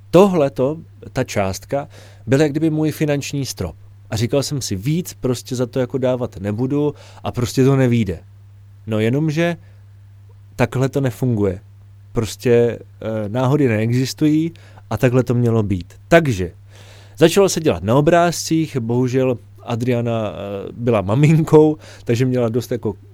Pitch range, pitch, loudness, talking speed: 100-140 Hz, 120 Hz, -18 LUFS, 130 wpm